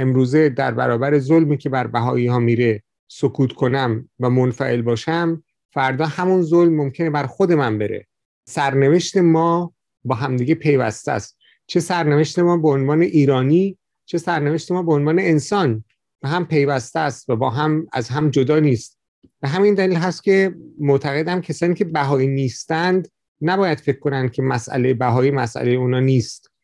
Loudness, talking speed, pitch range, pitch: -18 LUFS, 160 wpm, 130-165 Hz, 145 Hz